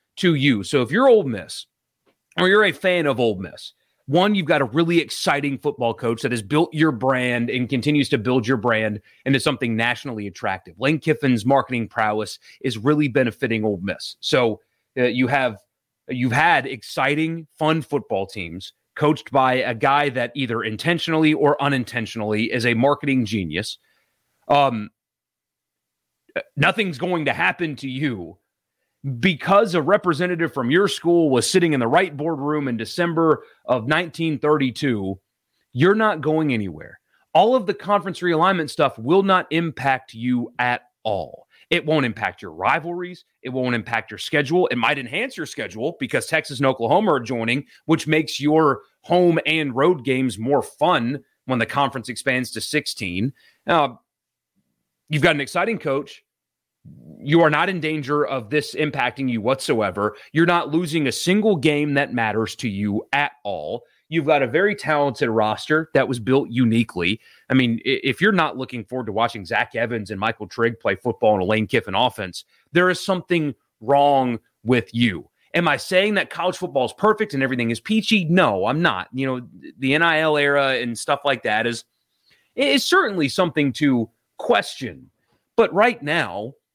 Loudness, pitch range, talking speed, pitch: -20 LUFS, 120-160 Hz, 165 wpm, 135 Hz